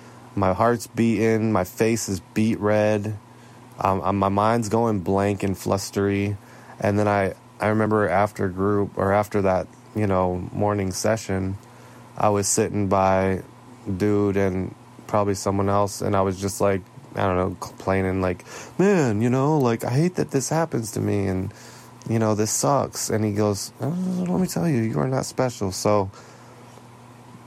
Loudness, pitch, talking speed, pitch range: -23 LUFS, 105 Hz, 170 wpm, 100-120 Hz